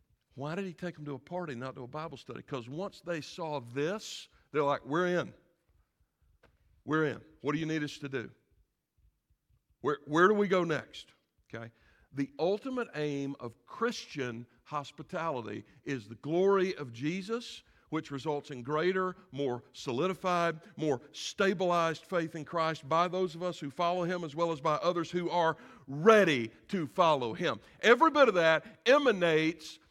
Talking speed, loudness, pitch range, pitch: 165 wpm, -31 LUFS, 140-180 Hz, 155 Hz